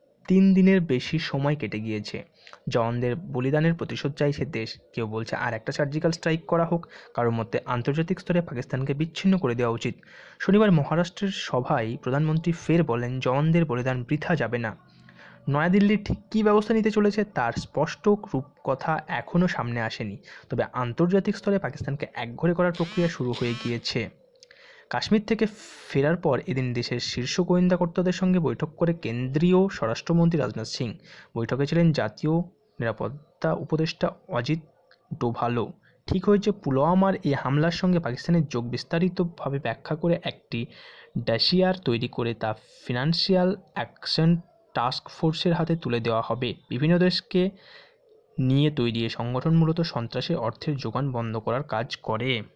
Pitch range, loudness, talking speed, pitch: 120-175 Hz, -25 LUFS, 140 wpm, 155 Hz